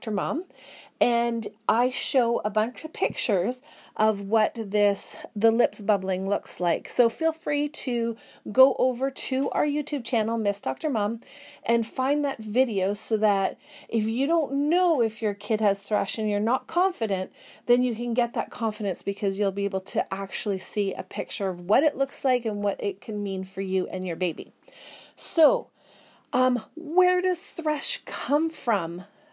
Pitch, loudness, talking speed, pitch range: 230 Hz, -26 LUFS, 175 wpm, 205-275 Hz